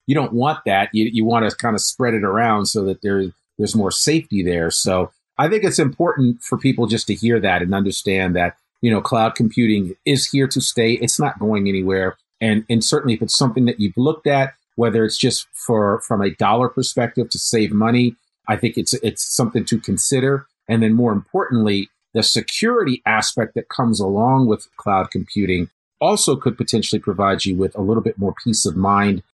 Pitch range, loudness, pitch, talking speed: 100-125 Hz, -18 LUFS, 115 Hz, 200 wpm